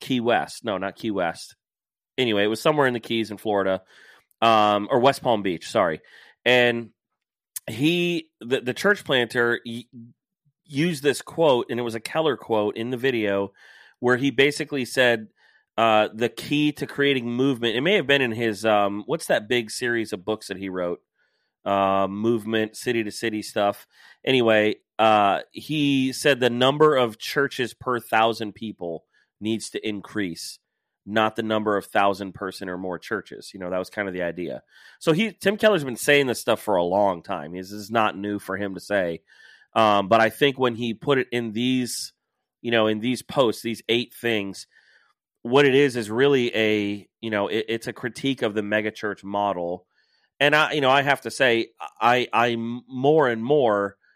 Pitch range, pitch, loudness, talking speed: 105-130 Hz, 115 Hz, -23 LUFS, 185 wpm